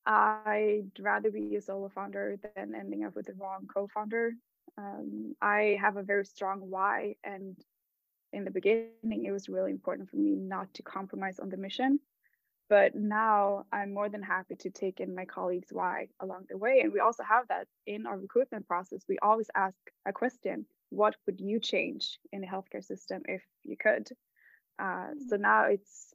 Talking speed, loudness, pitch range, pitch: 185 wpm, -32 LUFS, 190-220 Hz, 200 Hz